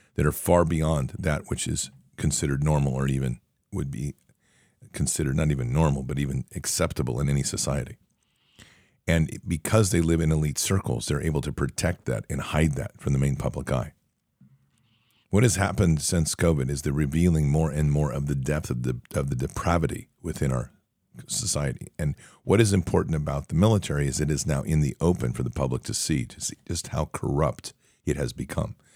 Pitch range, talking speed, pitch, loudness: 70-85 Hz, 190 wpm, 75 Hz, -26 LUFS